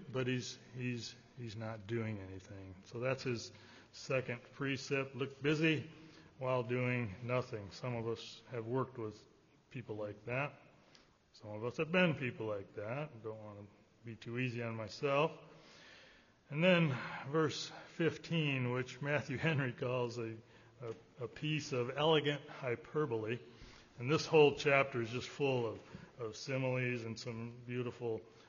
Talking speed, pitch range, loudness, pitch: 150 wpm, 115-145 Hz, -38 LUFS, 125 Hz